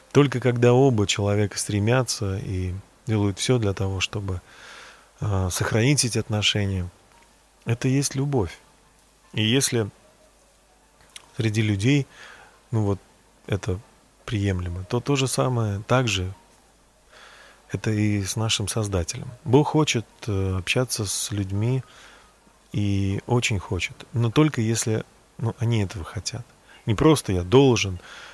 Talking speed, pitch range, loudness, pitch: 115 wpm, 100-125 Hz, -24 LUFS, 110 Hz